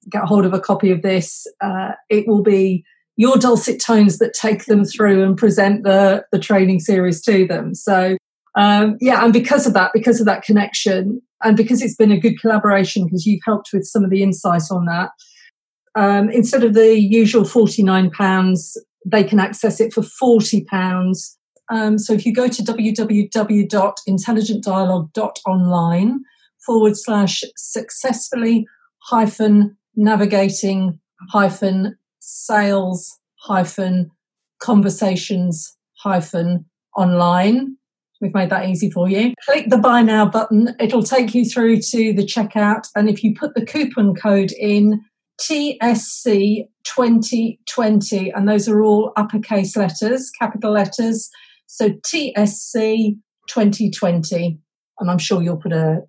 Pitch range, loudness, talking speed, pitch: 190-225 Hz, -16 LUFS, 140 wpm, 210 Hz